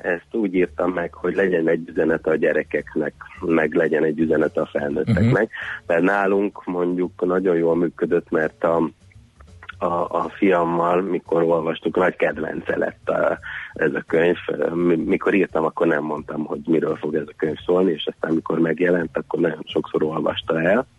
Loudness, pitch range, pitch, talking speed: -21 LUFS, 80-90 Hz, 85 Hz, 165 wpm